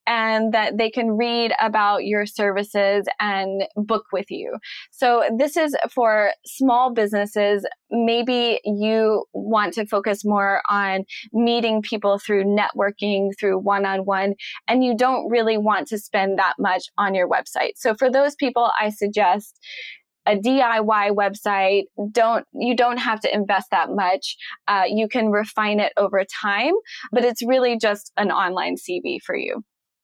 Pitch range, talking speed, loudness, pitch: 205-235 Hz, 150 wpm, -21 LUFS, 215 Hz